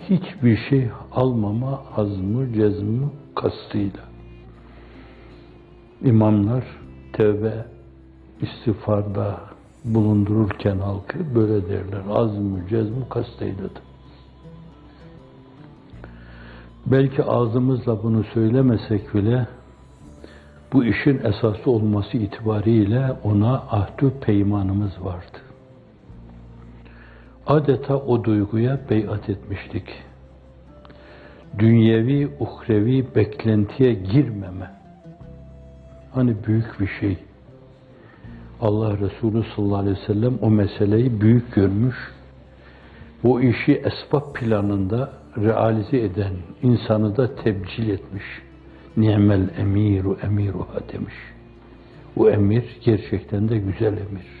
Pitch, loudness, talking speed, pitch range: 105 Hz, -21 LUFS, 80 wpm, 95-120 Hz